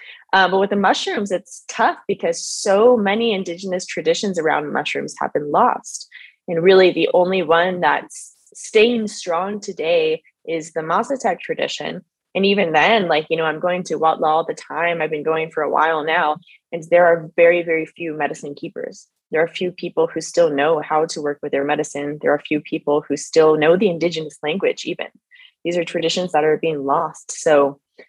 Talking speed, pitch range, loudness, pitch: 190 wpm, 155-200 Hz, -18 LUFS, 170 Hz